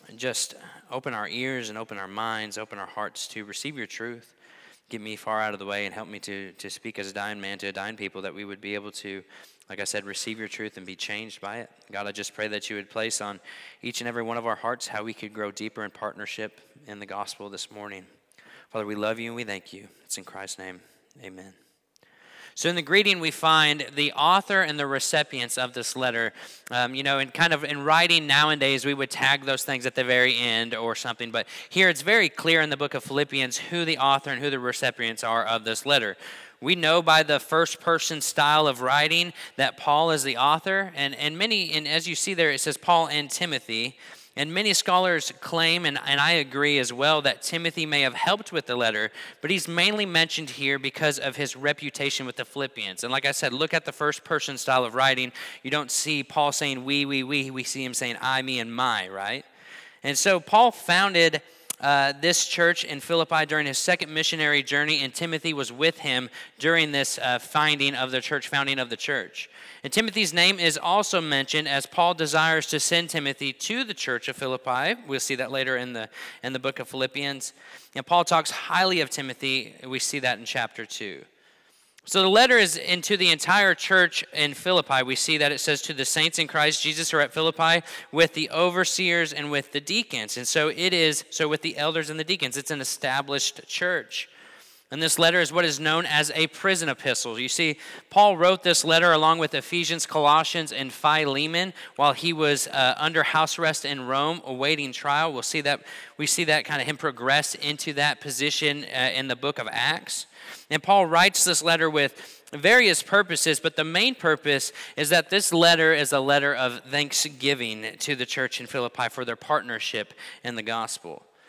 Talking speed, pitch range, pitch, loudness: 215 wpm, 125-160 Hz, 145 Hz, -23 LUFS